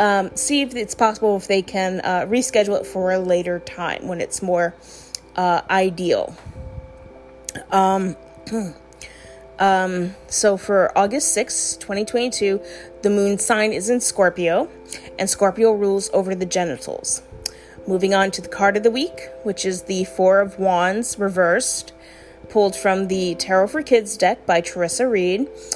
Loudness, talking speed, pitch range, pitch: -20 LUFS, 150 wpm, 175-205 Hz, 190 Hz